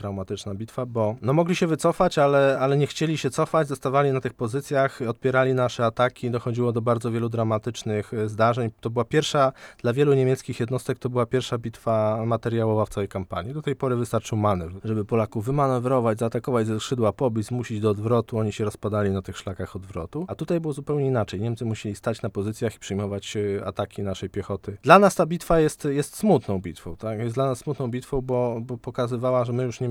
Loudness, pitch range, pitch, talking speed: -24 LUFS, 110-135 Hz, 120 Hz, 200 wpm